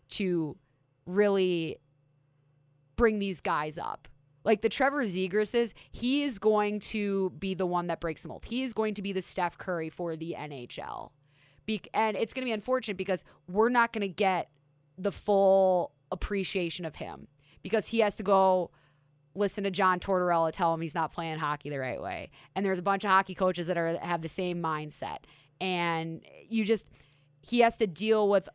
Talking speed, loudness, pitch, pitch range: 185 wpm, -30 LUFS, 185 Hz, 160-205 Hz